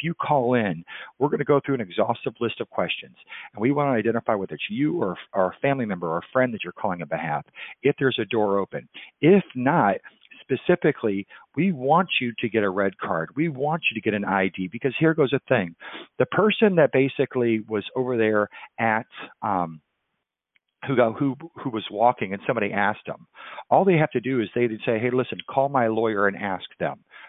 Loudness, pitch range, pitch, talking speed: -24 LUFS, 105-140 Hz, 120 Hz, 210 wpm